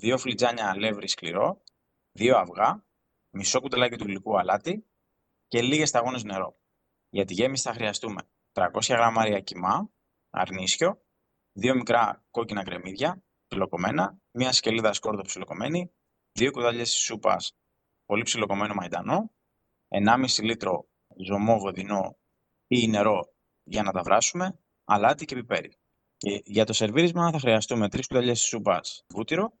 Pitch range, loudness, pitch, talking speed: 105-130 Hz, -26 LUFS, 115 Hz, 130 wpm